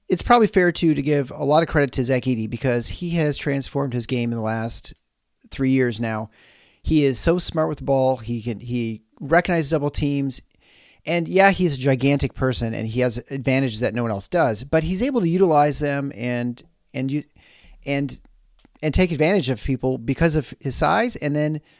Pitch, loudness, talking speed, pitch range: 140 Hz, -21 LUFS, 205 wpm, 125-155 Hz